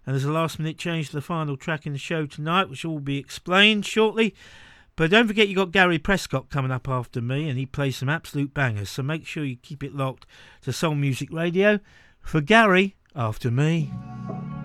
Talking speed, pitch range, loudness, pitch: 210 wpm, 135-175 Hz, -23 LUFS, 150 Hz